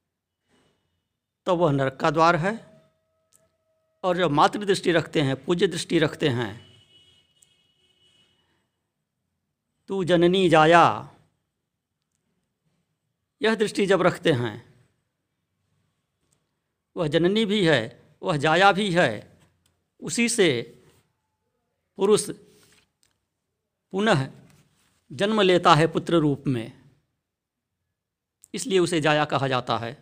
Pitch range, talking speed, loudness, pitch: 120-180 Hz, 95 wpm, -22 LUFS, 155 Hz